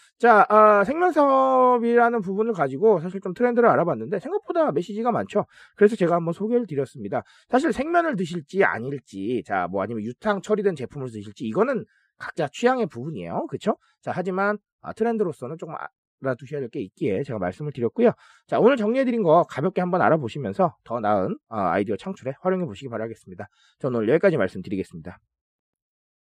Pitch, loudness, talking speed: 190 Hz, -23 LUFS, 425 characters per minute